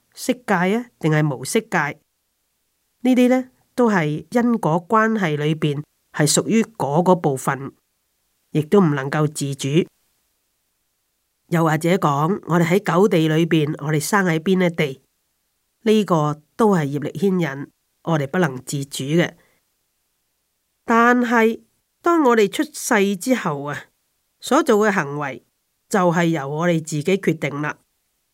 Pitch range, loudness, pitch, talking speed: 150-215 Hz, -19 LUFS, 175 Hz, 195 characters per minute